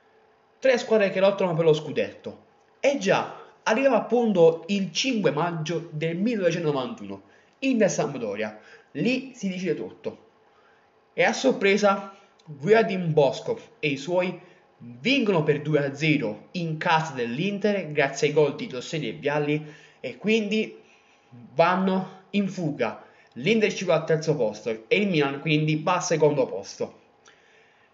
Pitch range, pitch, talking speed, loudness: 155-215 Hz, 180 Hz, 135 wpm, -24 LUFS